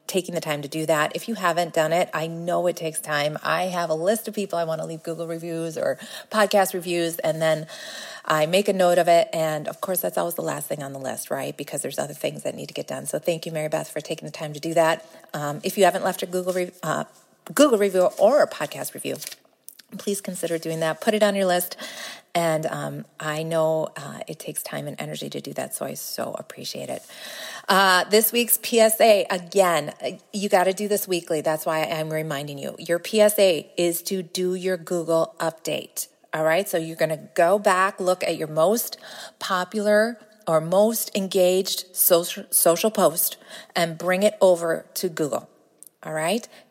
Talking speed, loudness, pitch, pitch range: 210 wpm, -23 LUFS, 175 Hz, 160-200 Hz